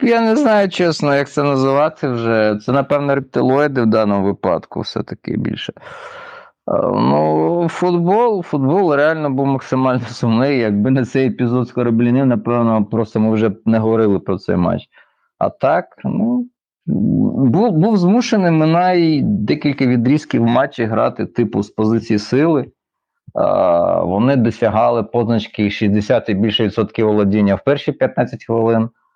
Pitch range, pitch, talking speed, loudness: 110-150 Hz, 125 Hz, 140 wpm, -16 LUFS